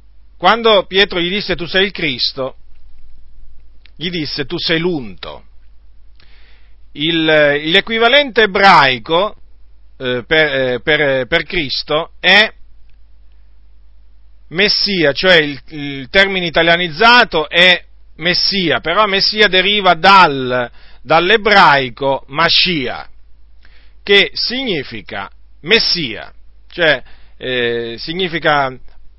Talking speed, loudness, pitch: 85 wpm, -12 LUFS, 140 Hz